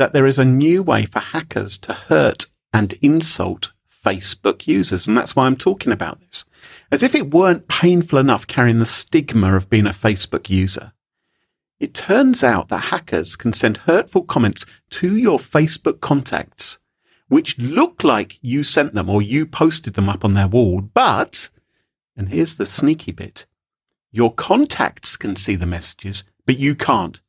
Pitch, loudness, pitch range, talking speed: 115 Hz, -17 LUFS, 100-150 Hz, 170 wpm